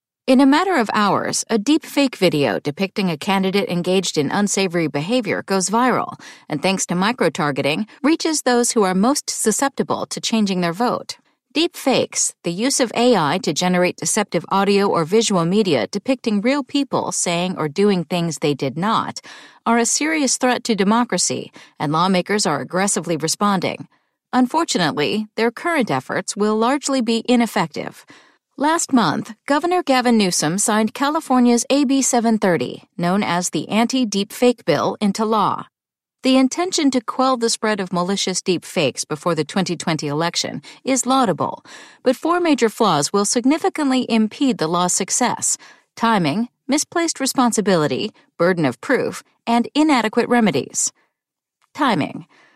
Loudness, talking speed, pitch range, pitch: -19 LUFS, 145 wpm, 180-255 Hz, 220 Hz